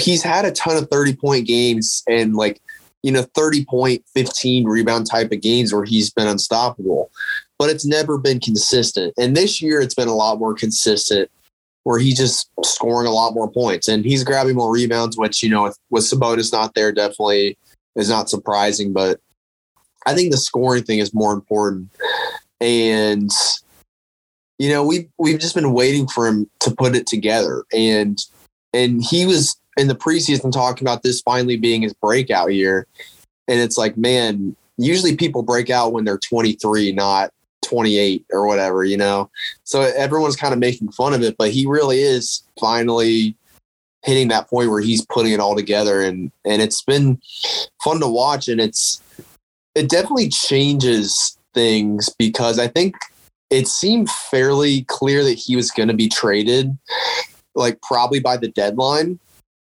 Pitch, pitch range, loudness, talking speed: 120 Hz, 105-135 Hz, -17 LUFS, 175 wpm